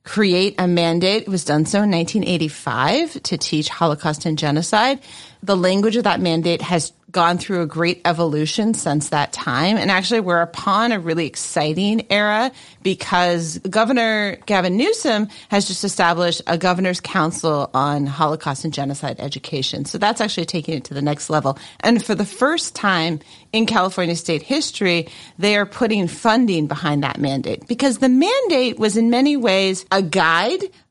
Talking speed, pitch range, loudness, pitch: 165 wpm, 160-215 Hz, -19 LUFS, 180 Hz